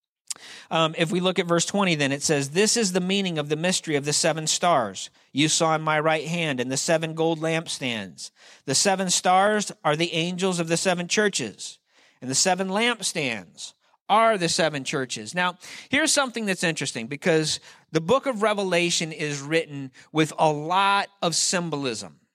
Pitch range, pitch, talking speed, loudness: 150-190 Hz, 165 Hz, 180 wpm, -23 LUFS